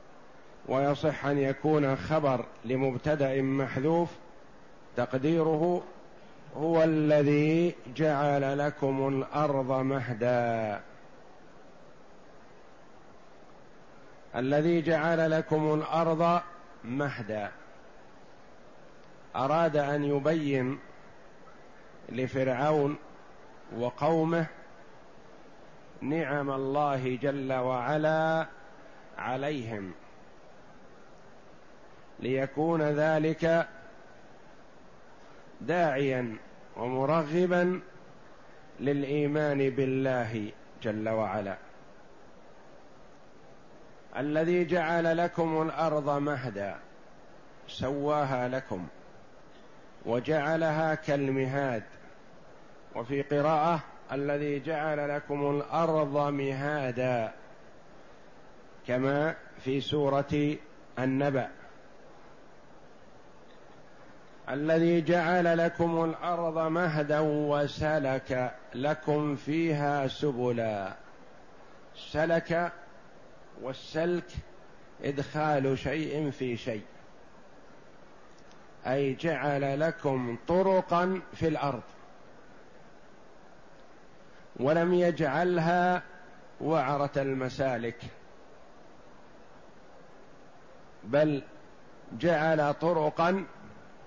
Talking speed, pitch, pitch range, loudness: 55 wpm, 145 Hz, 135-160 Hz, -29 LUFS